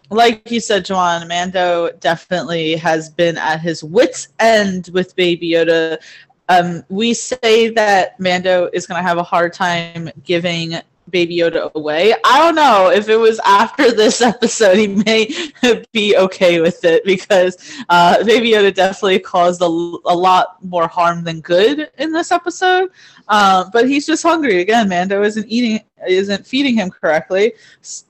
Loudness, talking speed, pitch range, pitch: -14 LUFS, 160 wpm, 175-225 Hz, 185 Hz